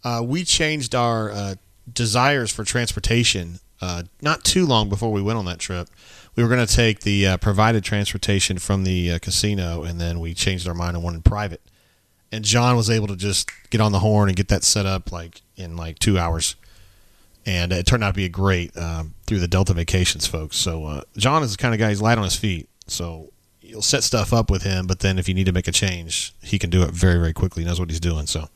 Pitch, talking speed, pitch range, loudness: 95 Hz, 245 wpm, 90-110 Hz, -21 LUFS